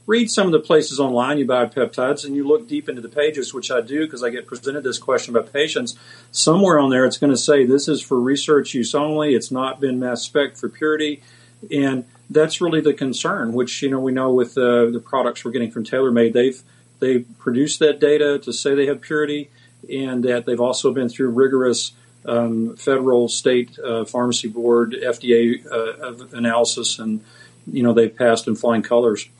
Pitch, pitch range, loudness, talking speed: 125 Hz, 120-145 Hz, -19 LUFS, 200 wpm